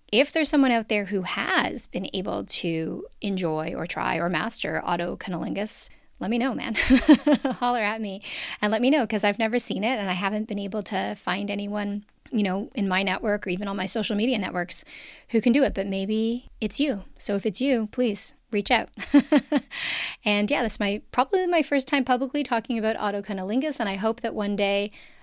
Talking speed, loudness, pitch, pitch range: 205 wpm, -25 LUFS, 220 Hz, 205-260 Hz